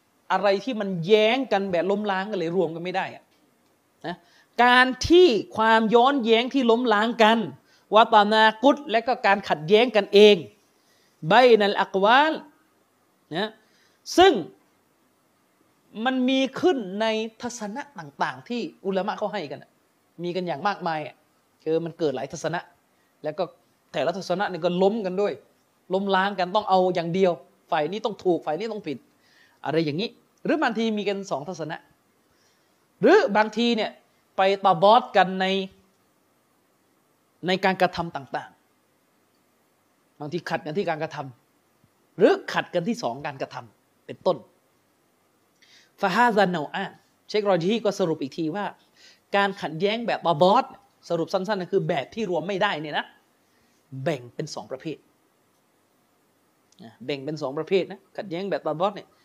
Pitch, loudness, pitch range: 195 Hz, -23 LUFS, 175-220 Hz